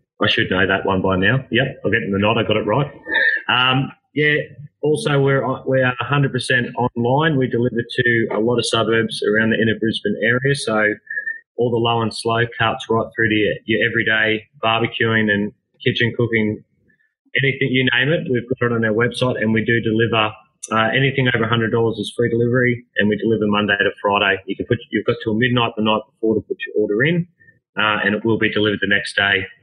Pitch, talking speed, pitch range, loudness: 115 Hz, 210 wpm, 110-130 Hz, -18 LUFS